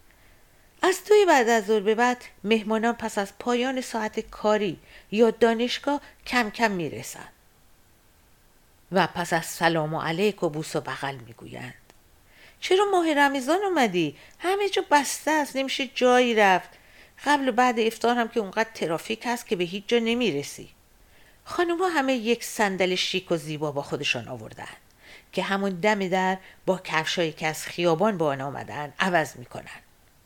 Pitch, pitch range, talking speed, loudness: 215 Hz, 165-250 Hz, 155 wpm, -24 LUFS